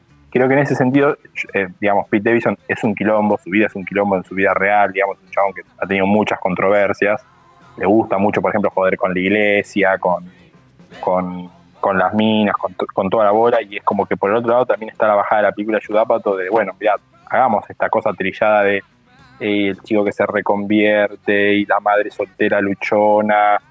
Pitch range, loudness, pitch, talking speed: 95-105 Hz, -17 LUFS, 100 Hz, 210 wpm